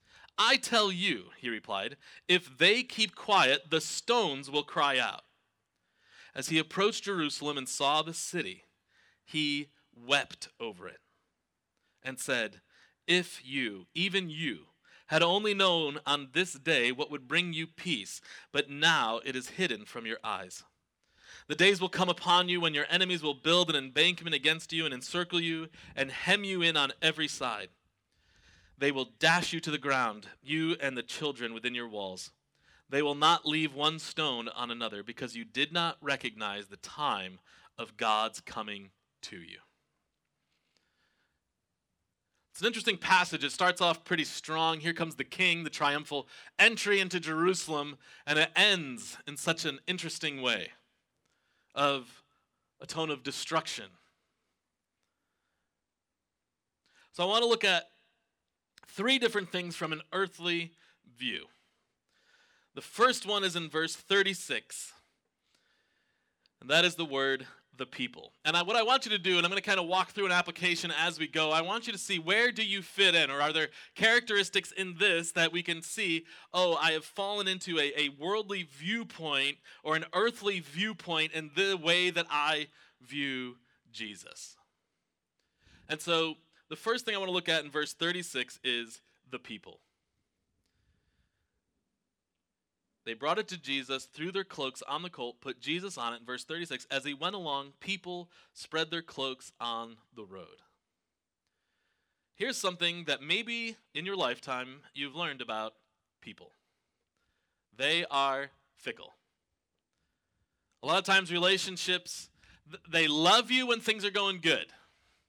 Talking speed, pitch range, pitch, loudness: 155 wpm, 135-180 Hz, 160 Hz, -30 LUFS